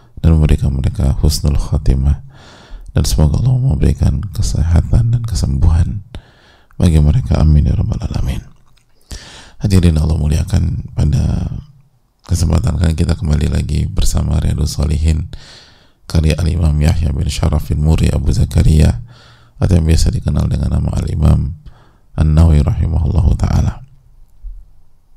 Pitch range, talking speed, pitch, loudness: 75-95 Hz, 120 wpm, 85 Hz, -15 LUFS